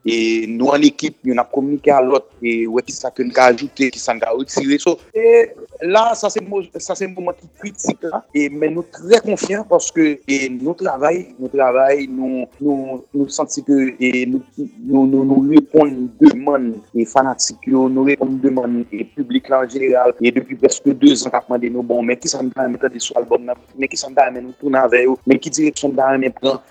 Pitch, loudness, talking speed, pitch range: 135 Hz, -16 LUFS, 195 wpm, 125-170 Hz